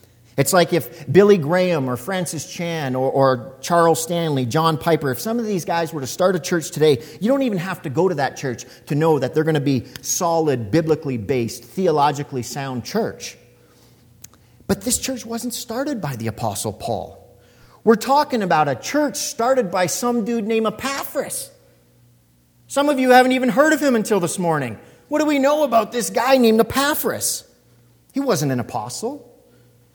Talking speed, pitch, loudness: 180 wpm, 165 Hz, -20 LUFS